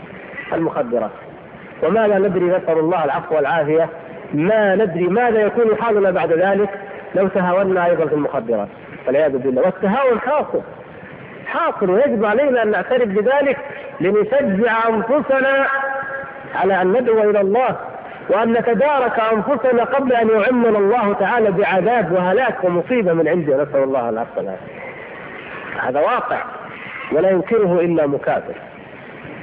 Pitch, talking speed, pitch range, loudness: 210 Hz, 120 wpm, 180-245 Hz, -17 LUFS